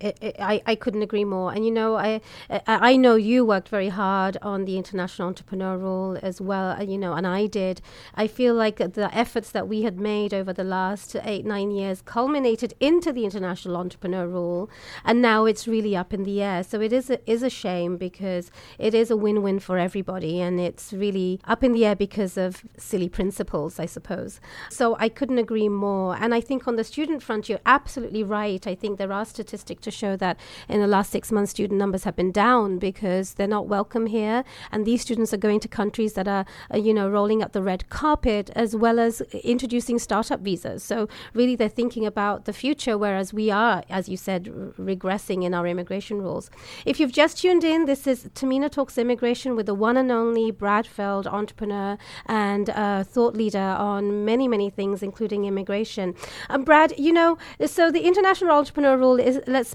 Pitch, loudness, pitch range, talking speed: 210 Hz, -24 LUFS, 195-230 Hz, 205 wpm